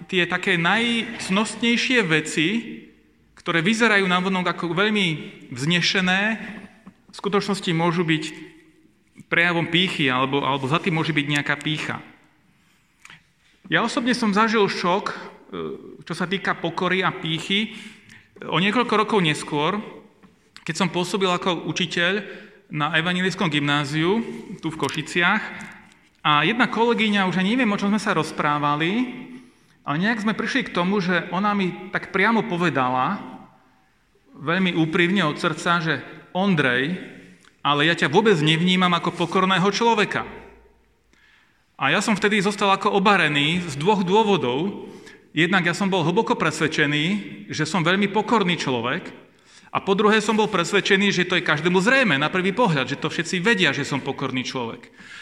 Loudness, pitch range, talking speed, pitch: -21 LUFS, 160-210 Hz, 140 wpm, 185 Hz